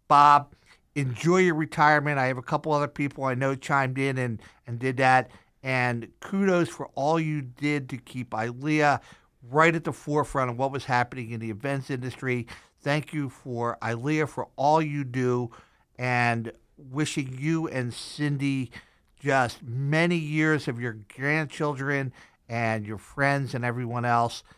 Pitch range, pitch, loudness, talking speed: 125-150 Hz, 135 Hz, -26 LUFS, 155 wpm